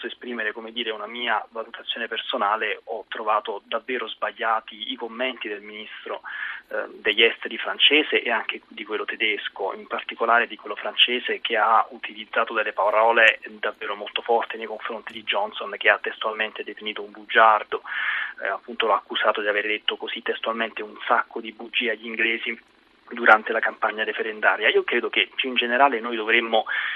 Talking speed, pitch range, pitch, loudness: 160 wpm, 110-130 Hz, 115 Hz, -23 LUFS